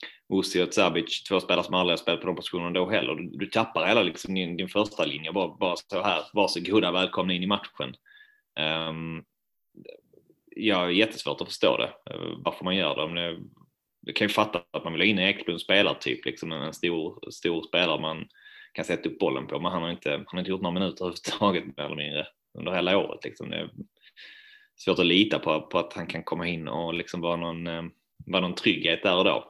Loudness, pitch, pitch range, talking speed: -27 LUFS, 90 Hz, 85-105 Hz, 220 wpm